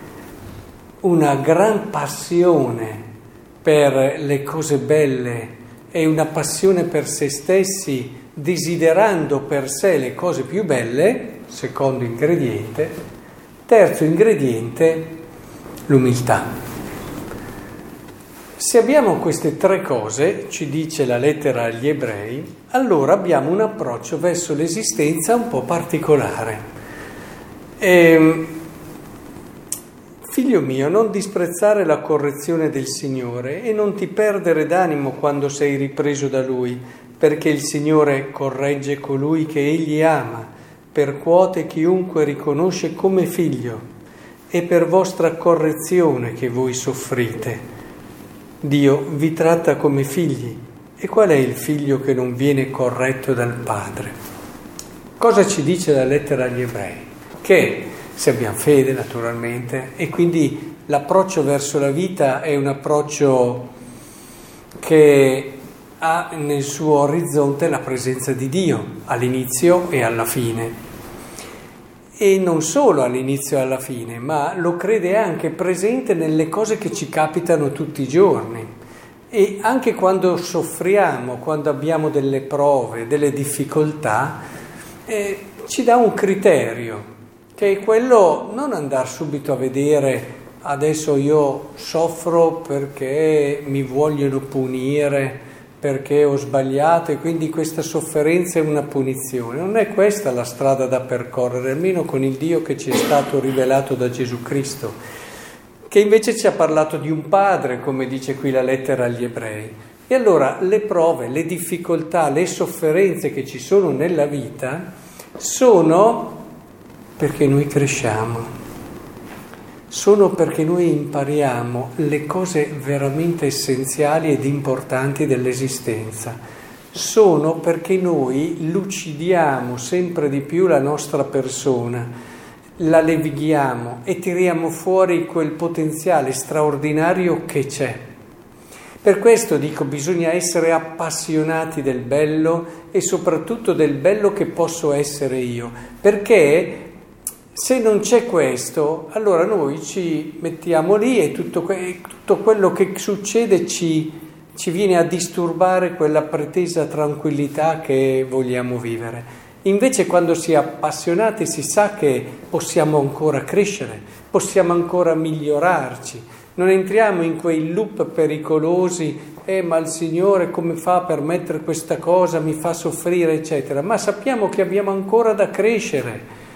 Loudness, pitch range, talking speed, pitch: -18 LUFS, 135-170 Hz, 125 wpm, 155 Hz